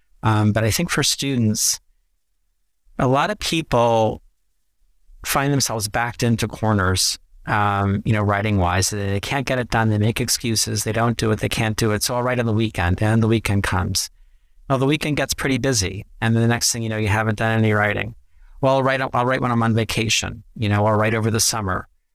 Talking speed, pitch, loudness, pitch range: 215 wpm, 110 Hz, -20 LUFS, 105-120 Hz